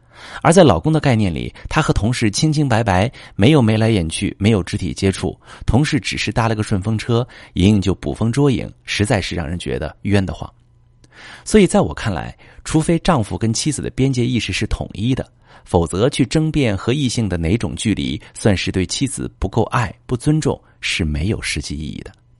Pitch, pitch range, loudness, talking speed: 110 Hz, 95-125 Hz, -18 LUFS, 290 characters per minute